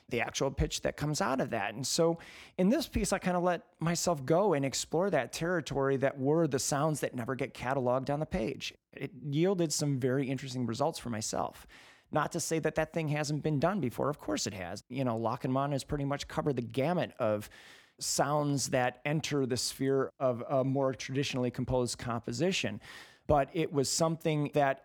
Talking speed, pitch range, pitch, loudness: 200 wpm, 130-160 Hz, 140 Hz, -32 LUFS